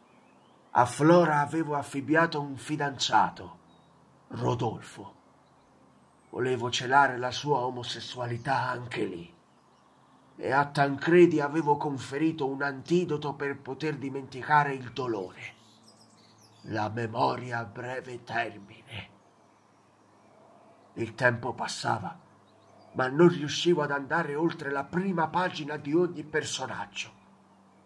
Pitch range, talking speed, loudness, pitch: 125-155 Hz, 100 wpm, -28 LUFS, 140 Hz